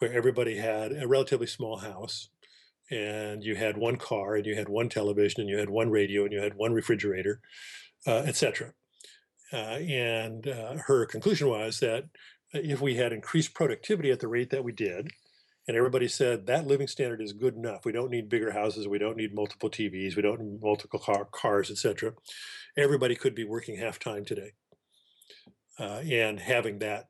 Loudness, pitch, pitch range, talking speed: -30 LUFS, 115 Hz, 105-125 Hz, 185 wpm